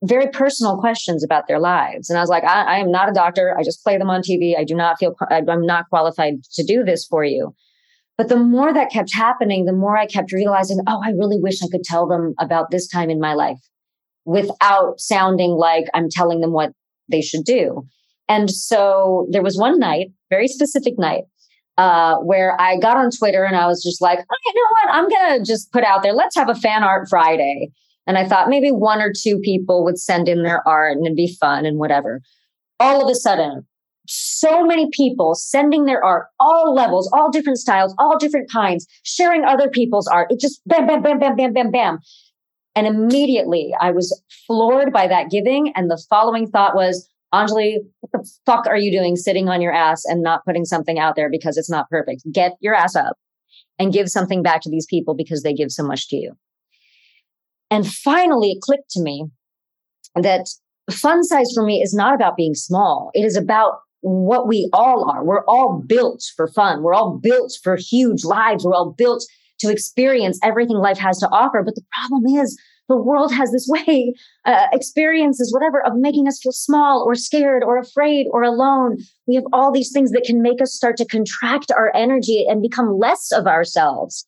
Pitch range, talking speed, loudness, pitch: 175-255 Hz, 210 wpm, -17 LUFS, 205 Hz